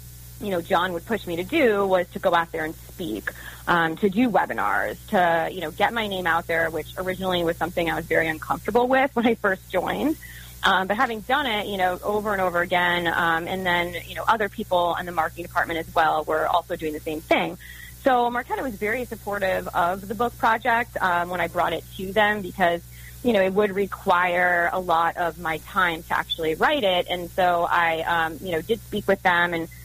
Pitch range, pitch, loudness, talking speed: 165-205 Hz, 175 Hz, -23 LUFS, 225 wpm